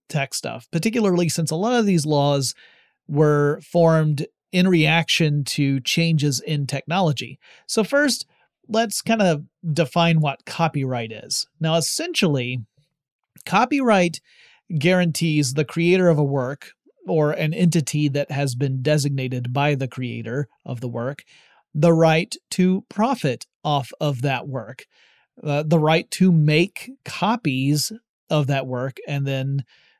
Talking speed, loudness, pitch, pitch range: 135 wpm, -21 LUFS, 155 Hz, 140-175 Hz